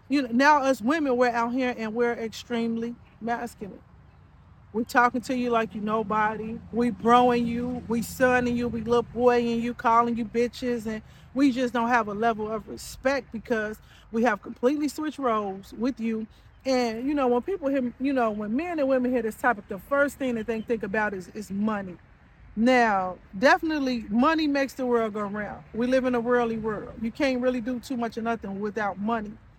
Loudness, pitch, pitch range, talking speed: -26 LUFS, 235 Hz, 225-255 Hz, 200 wpm